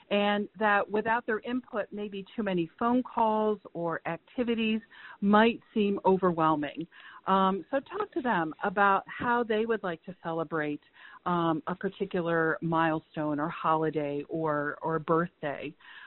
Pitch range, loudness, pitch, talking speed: 160-215 Hz, -29 LUFS, 185 Hz, 135 wpm